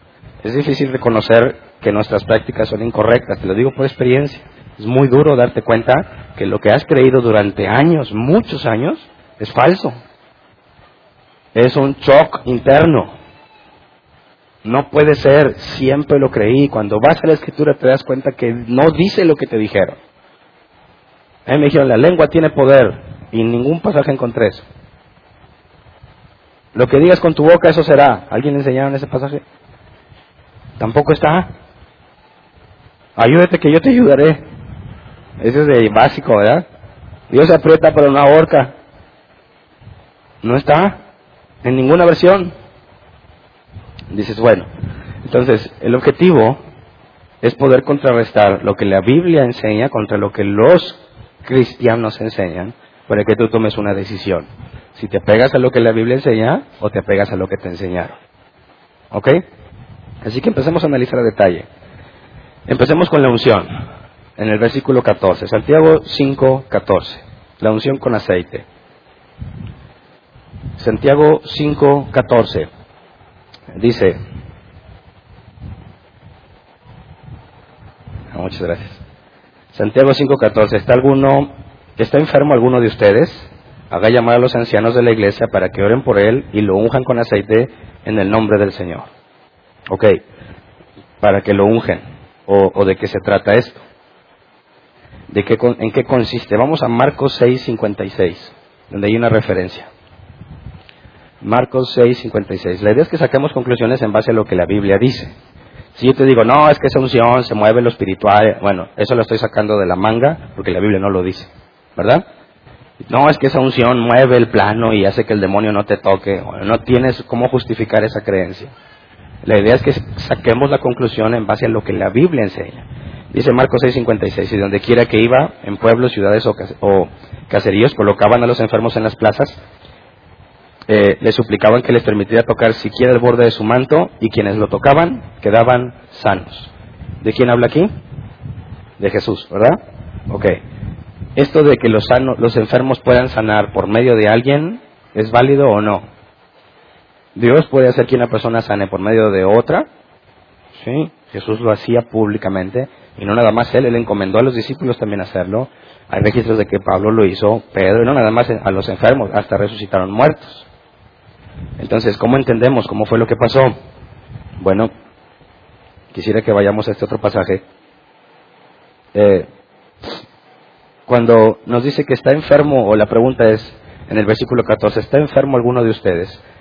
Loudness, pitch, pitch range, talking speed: -13 LUFS, 115 Hz, 105-130 Hz, 155 wpm